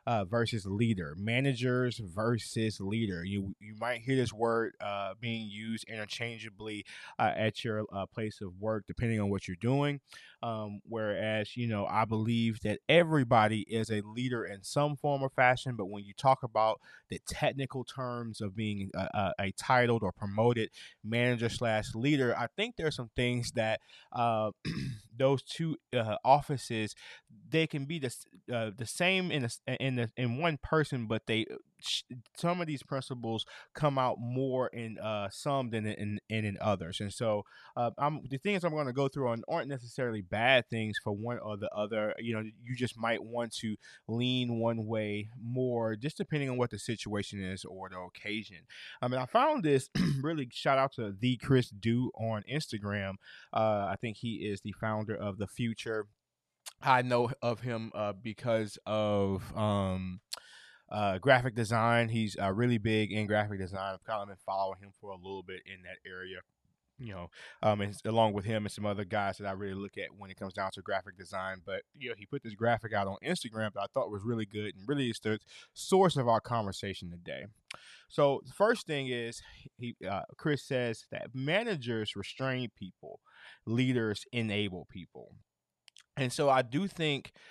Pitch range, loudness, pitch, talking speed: 105-125 Hz, -33 LUFS, 115 Hz, 185 wpm